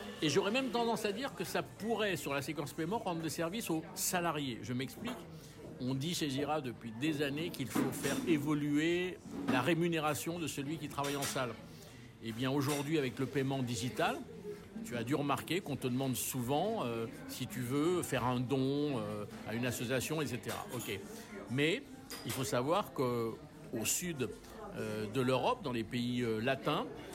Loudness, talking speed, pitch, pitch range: -36 LUFS, 180 wpm, 145 Hz, 125-165 Hz